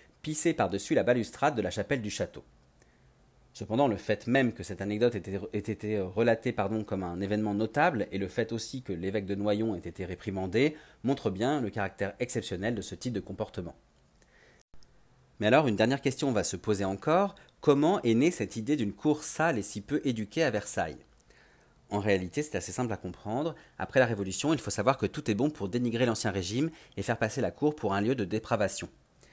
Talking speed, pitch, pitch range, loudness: 205 wpm, 110 Hz, 100-125 Hz, -30 LUFS